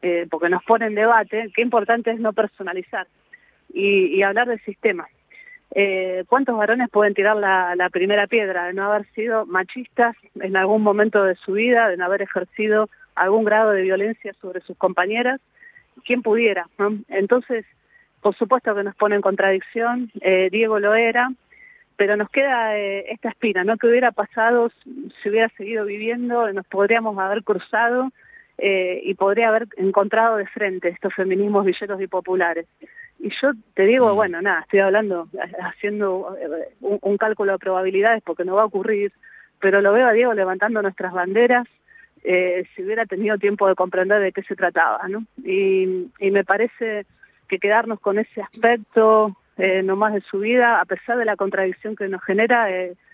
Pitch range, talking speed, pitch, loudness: 195-230 Hz, 175 wpm, 210 Hz, -20 LUFS